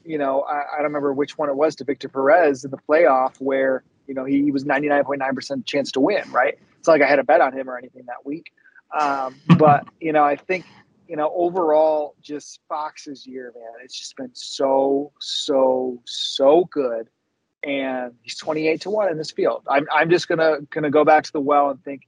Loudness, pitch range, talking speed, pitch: -20 LUFS, 135-155 Hz, 215 wpm, 145 Hz